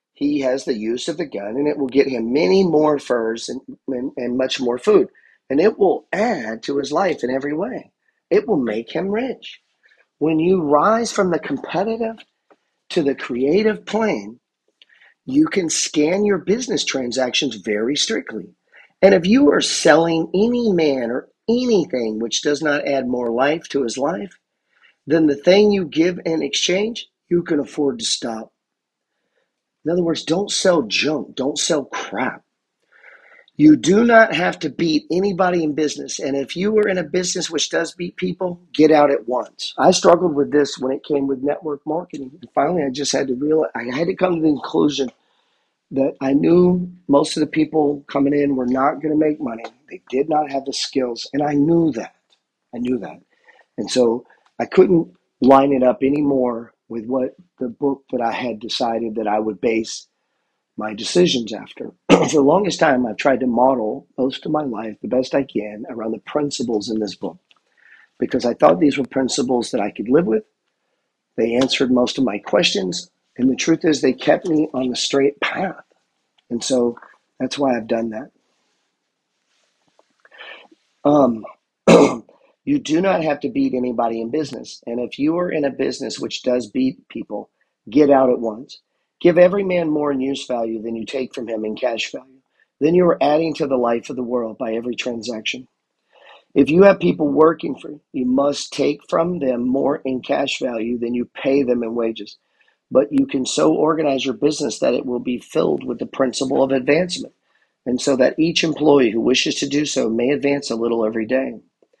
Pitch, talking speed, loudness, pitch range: 140 Hz, 190 wpm, -19 LUFS, 125-165 Hz